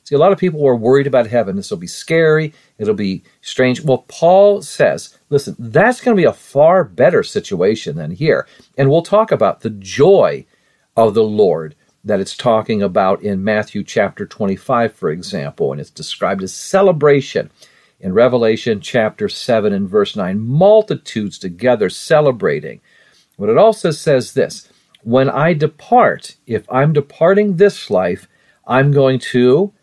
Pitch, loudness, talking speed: 140 Hz, -15 LUFS, 160 wpm